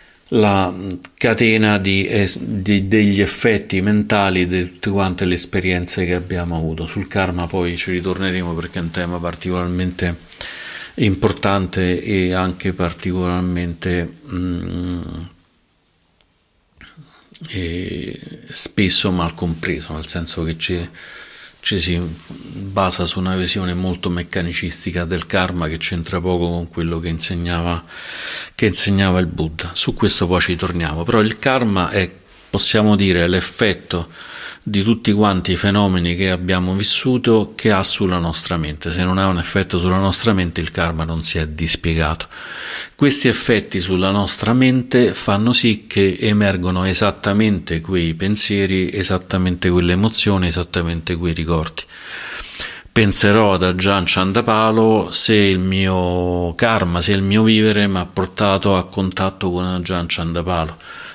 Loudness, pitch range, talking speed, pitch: -17 LUFS, 85-100 Hz, 130 wpm, 90 Hz